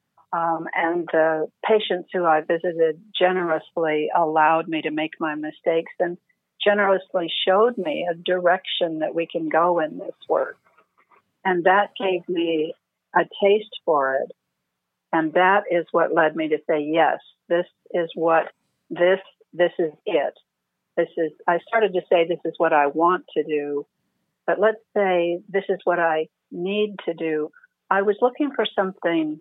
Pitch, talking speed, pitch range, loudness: 170 Hz, 160 wpm, 160-190 Hz, -22 LUFS